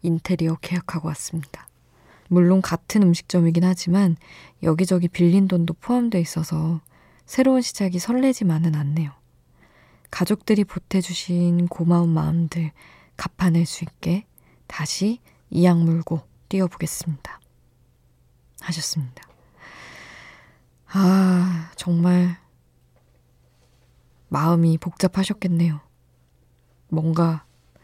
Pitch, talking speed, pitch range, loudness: 170 Hz, 230 characters per minute, 160-180 Hz, -21 LUFS